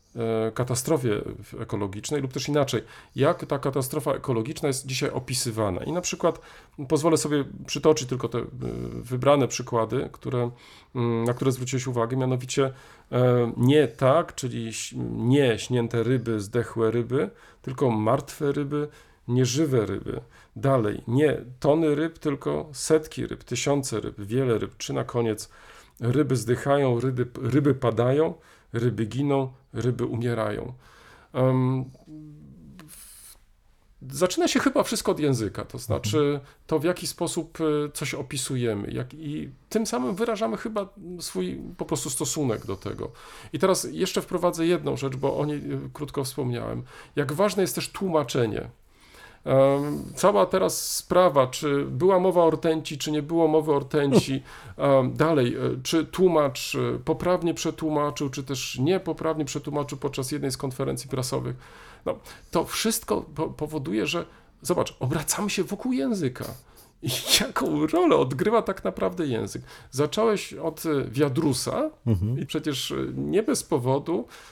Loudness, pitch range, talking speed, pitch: -26 LUFS, 120-155 Hz, 130 wpm, 140 Hz